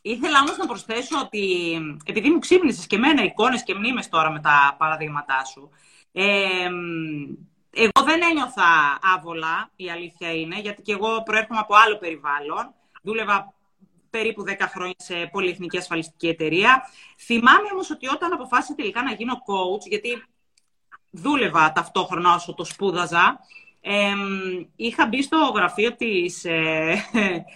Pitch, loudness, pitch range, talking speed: 200 Hz, -21 LUFS, 175-240 Hz, 140 wpm